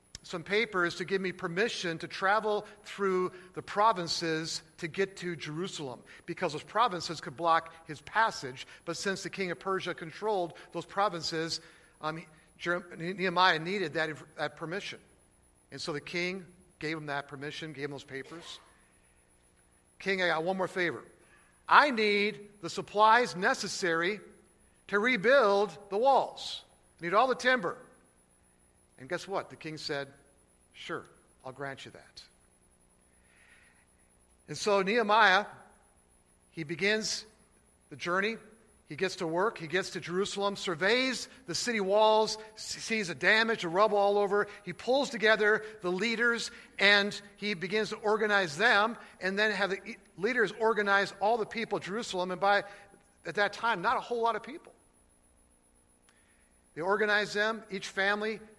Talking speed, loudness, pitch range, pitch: 145 wpm, -30 LUFS, 155-210 Hz, 185 Hz